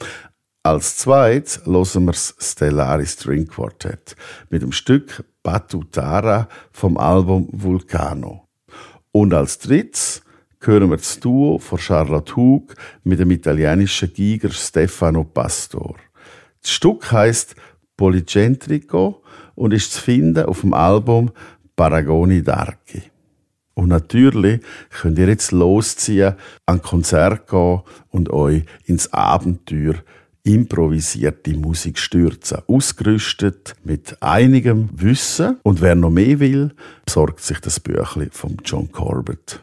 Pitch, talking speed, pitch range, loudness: 95 Hz, 115 wpm, 80-110 Hz, -17 LUFS